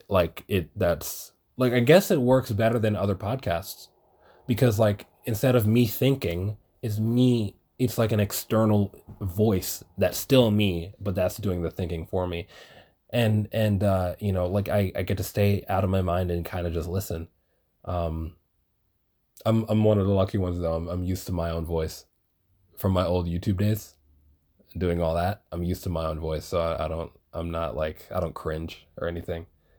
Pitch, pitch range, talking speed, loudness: 95 Hz, 85-110 Hz, 195 wpm, -26 LUFS